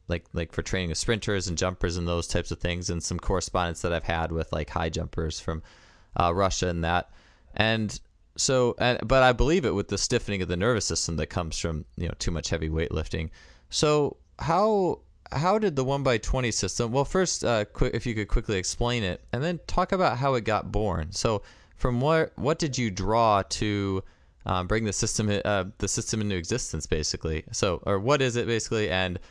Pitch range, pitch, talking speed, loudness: 85-120 Hz, 100 Hz, 215 wpm, -27 LUFS